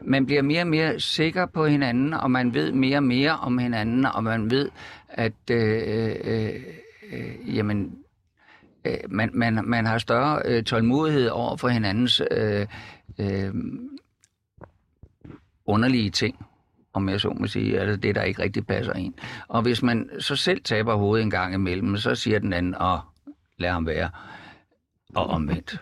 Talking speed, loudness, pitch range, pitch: 165 wpm, -24 LUFS, 100-130 Hz, 115 Hz